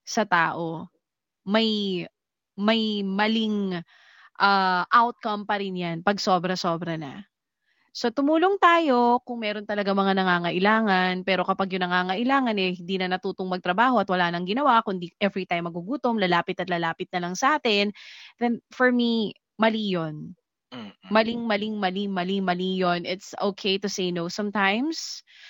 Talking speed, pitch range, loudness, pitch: 140 wpm, 180-220 Hz, -24 LUFS, 195 Hz